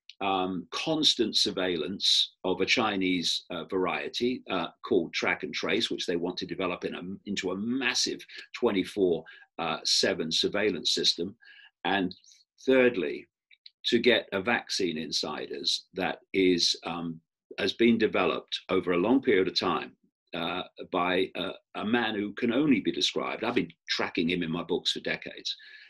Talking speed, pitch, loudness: 155 wpm, 115 Hz, -28 LUFS